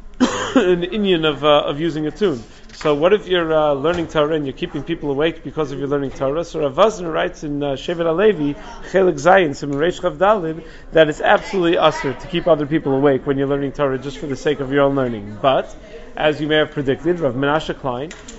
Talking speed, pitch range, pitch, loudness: 215 wpm, 140-175 Hz, 155 Hz, -18 LUFS